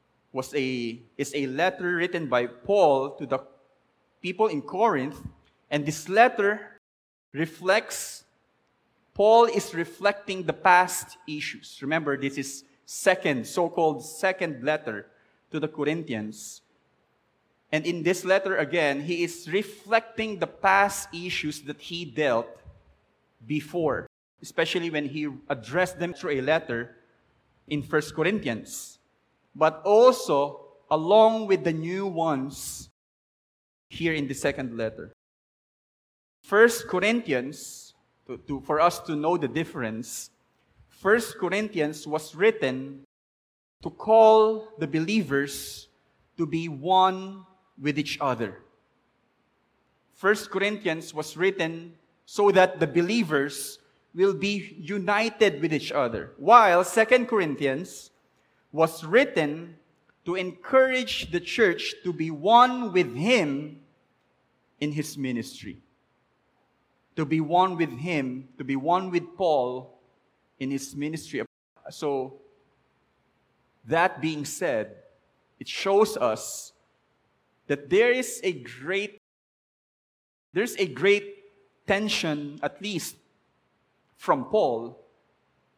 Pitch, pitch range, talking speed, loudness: 165 Hz, 140-195 Hz, 110 wpm, -25 LUFS